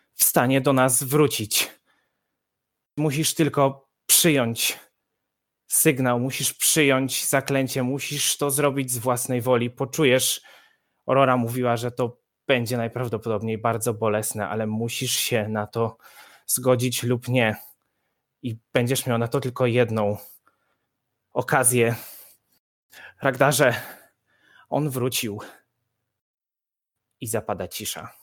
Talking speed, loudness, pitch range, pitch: 105 wpm, -22 LUFS, 115-135 Hz, 125 Hz